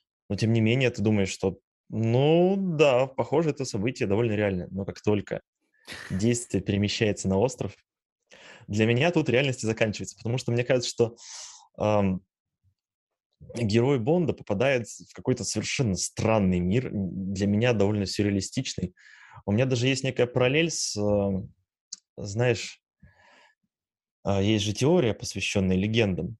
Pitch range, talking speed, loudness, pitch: 100-125 Hz, 135 wpm, -26 LUFS, 110 Hz